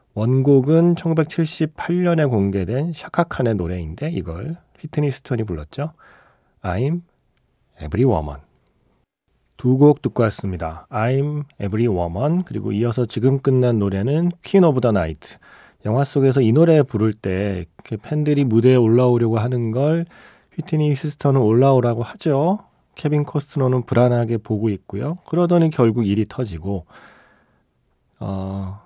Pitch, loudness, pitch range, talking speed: 125 Hz, -19 LUFS, 105-150 Hz, 315 characters per minute